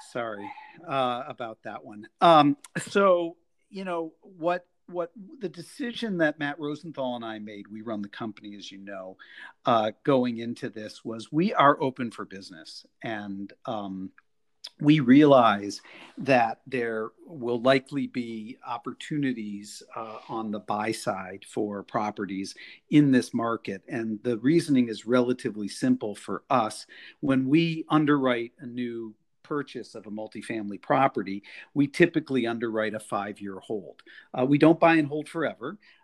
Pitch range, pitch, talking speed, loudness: 110-150 Hz, 125 Hz, 145 wpm, -26 LUFS